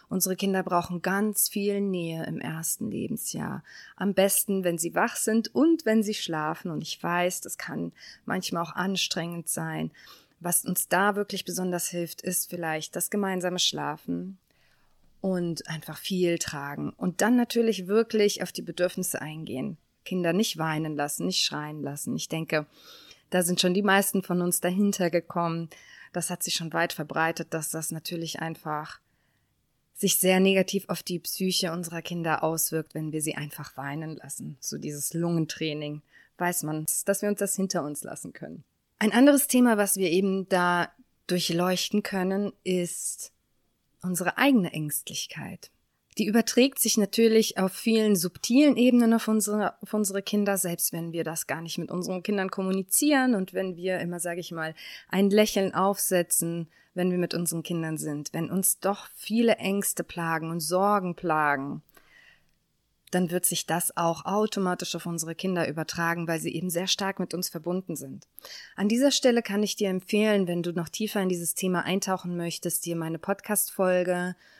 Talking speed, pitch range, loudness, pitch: 165 wpm, 165-200 Hz, -27 LUFS, 180 Hz